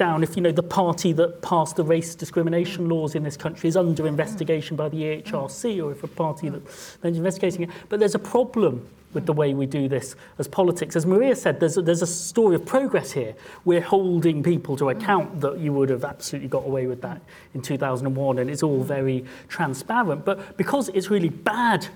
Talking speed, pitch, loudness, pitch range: 210 wpm, 165 Hz, -23 LUFS, 145-185 Hz